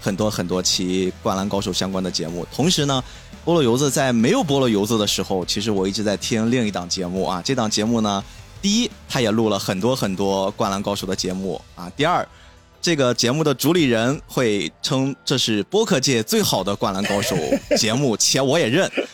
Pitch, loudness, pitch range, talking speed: 105 Hz, -20 LUFS, 95-130 Hz, 305 characters per minute